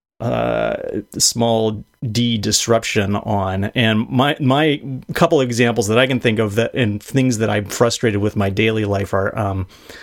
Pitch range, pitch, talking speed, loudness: 105-125 Hz, 115 Hz, 160 wpm, -18 LUFS